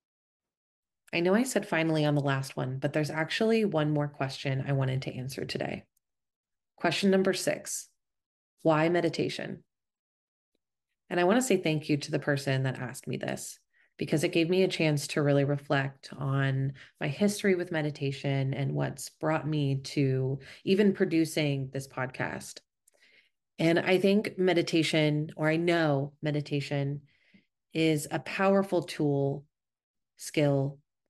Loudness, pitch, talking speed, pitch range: -29 LUFS, 150 Hz, 145 wpm, 140-170 Hz